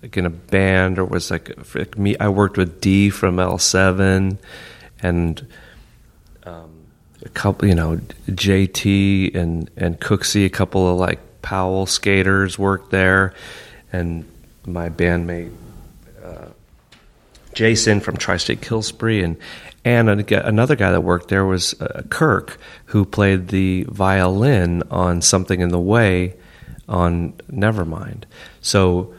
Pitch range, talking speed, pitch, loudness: 90-100 Hz, 130 wpm, 95 Hz, -18 LUFS